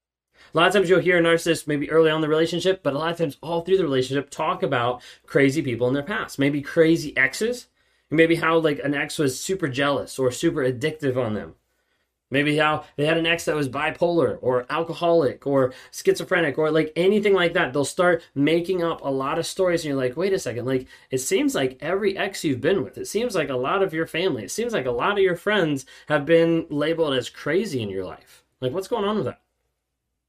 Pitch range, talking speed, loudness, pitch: 135-170 Hz, 230 wpm, -22 LUFS, 155 Hz